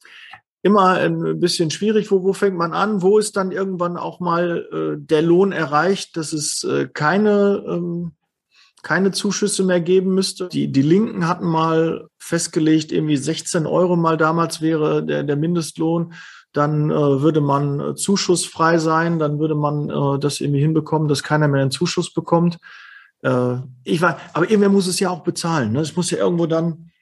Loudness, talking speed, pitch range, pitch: -19 LUFS, 180 wpm, 155-185 Hz, 170 Hz